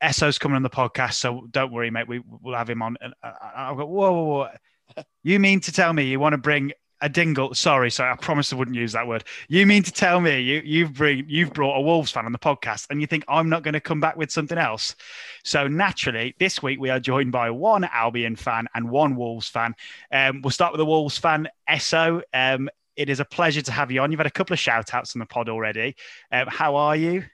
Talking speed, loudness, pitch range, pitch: 250 wpm, -22 LUFS, 125-160 Hz, 145 Hz